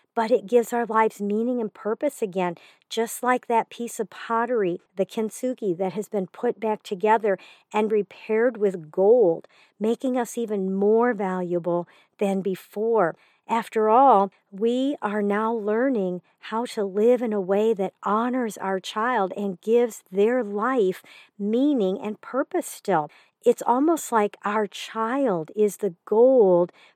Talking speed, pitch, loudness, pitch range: 145 wpm, 220 Hz, -24 LUFS, 200-235 Hz